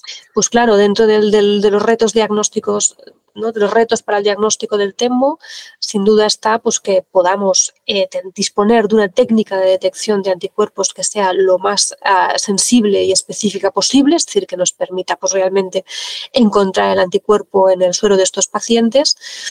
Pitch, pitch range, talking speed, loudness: 205 Hz, 190-225 Hz, 180 wpm, -14 LUFS